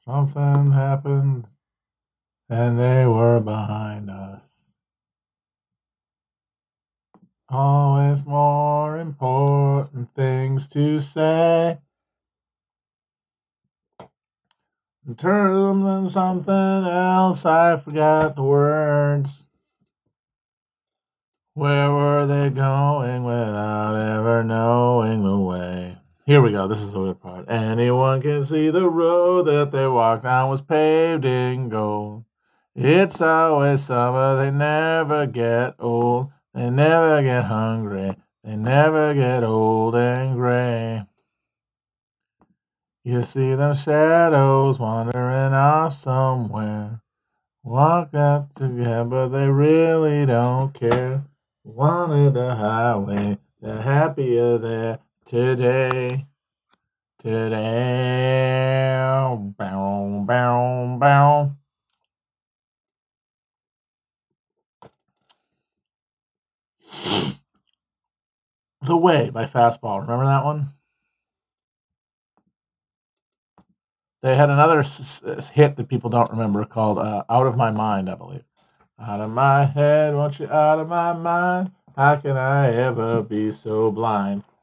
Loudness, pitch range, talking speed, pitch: -20 LUFS, 115-145 Hz, 100 wpm, 130 Hz